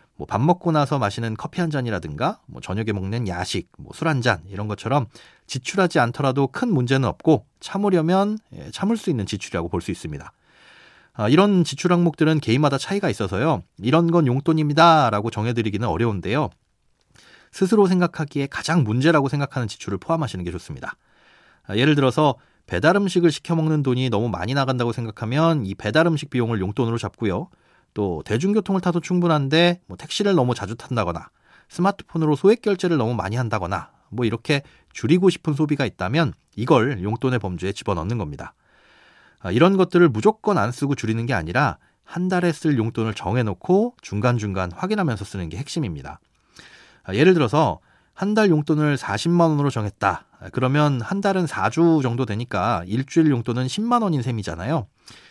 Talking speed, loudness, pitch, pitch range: 375 characters per minute, -21 LUFS, 135 Hz, 110-170 Hz